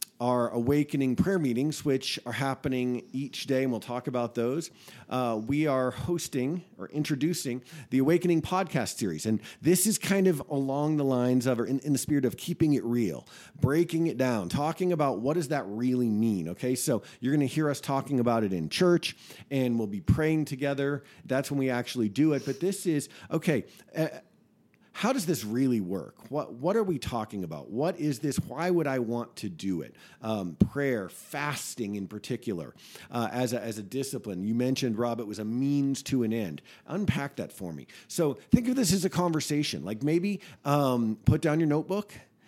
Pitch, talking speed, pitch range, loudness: 135 Hz, 195 wpm, 120-155 Hz, -29 LUFS